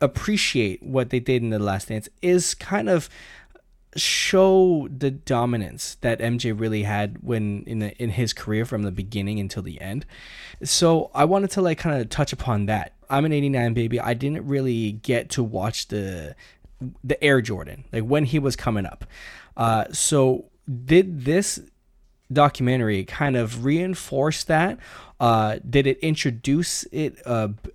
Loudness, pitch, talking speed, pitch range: -23 LUFS, 125 Hz, 160 wpm, 110-145 Hz